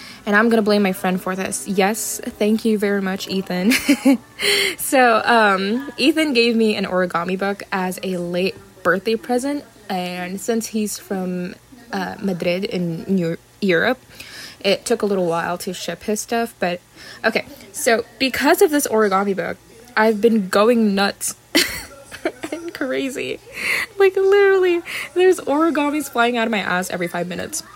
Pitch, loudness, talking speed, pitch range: 215 Hz, -19 LUFS, 155 wpm, 185-260 Hz